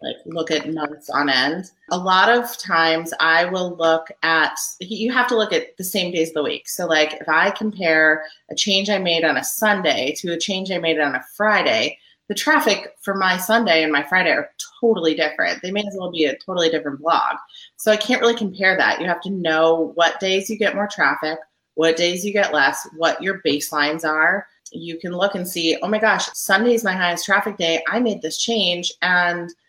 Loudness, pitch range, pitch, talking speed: -19 LUFS, 160-205 Hz, 180 Hz, 220 wpm